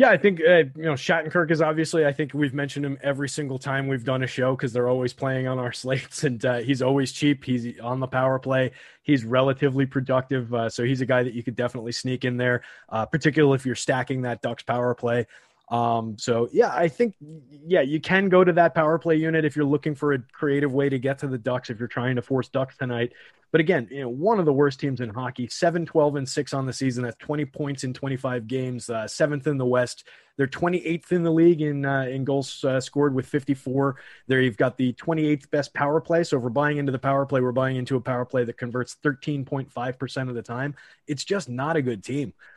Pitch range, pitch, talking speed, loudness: 125-150 Hz, 135 Hz, 250 wpm, -24 LUFS